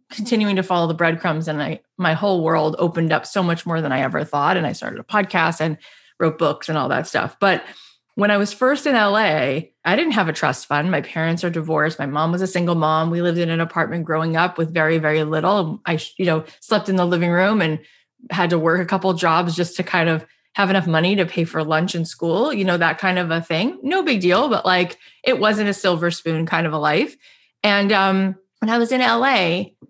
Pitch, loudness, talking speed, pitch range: 175 Hz, -19 LUFS, 245 wpm, 160-195 Hz